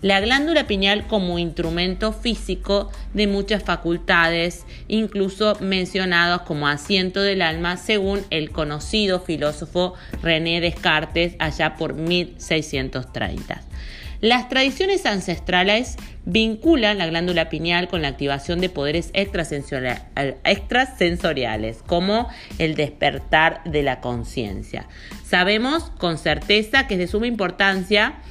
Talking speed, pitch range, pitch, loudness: 110 wpm, 160-205 Hz, 175 Hz, -20 LUFS